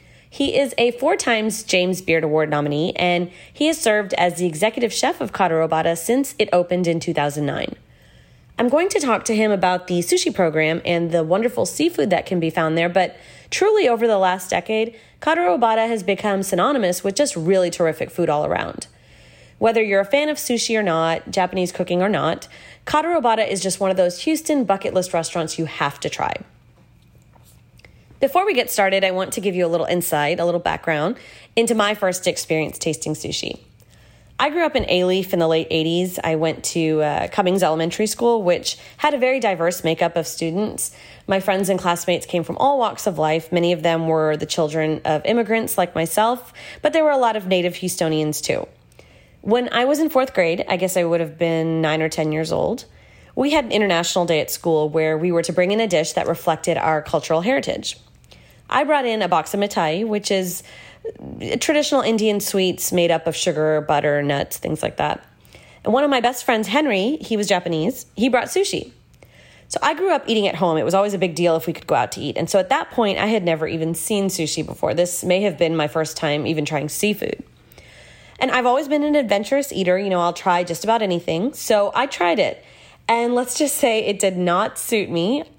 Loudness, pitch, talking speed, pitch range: -20 LUFS, 185 Hz, 210 wpm, 165-230 Hz